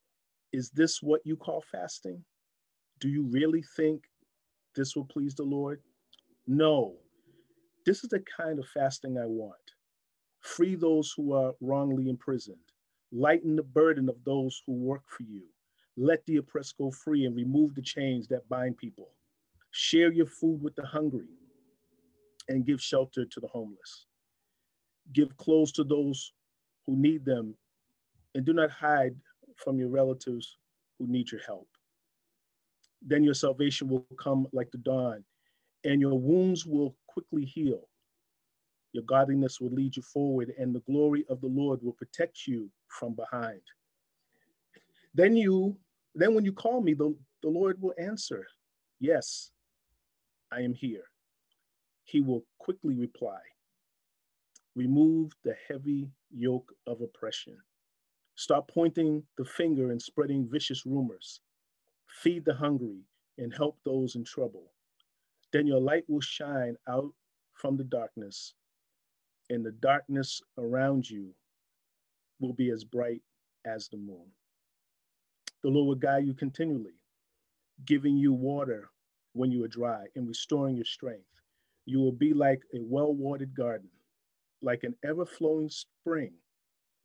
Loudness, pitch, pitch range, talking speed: -30 LUFS, 135 Hz, 125-150 Hz, 140 wpm